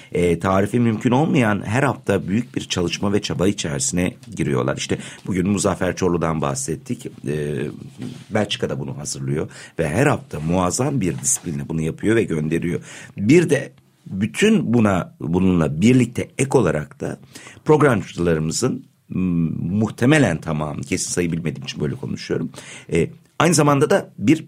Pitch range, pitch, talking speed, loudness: 80-125 Hz, 95 Hz, 125 wpm, -20 LUFS